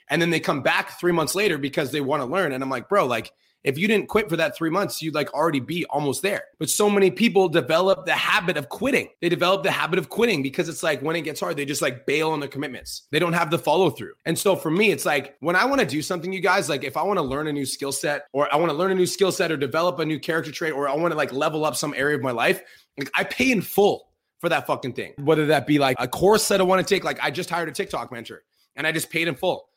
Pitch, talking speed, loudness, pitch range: 165 Hz, 305 wpm, -22 LUFS, 150-185 Hz